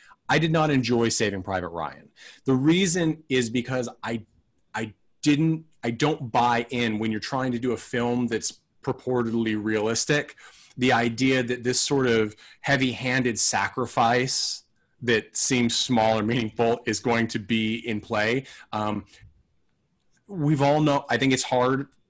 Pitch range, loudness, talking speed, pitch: 110-130 Hz, -24 LUFS, 150 wpm, 120 Hz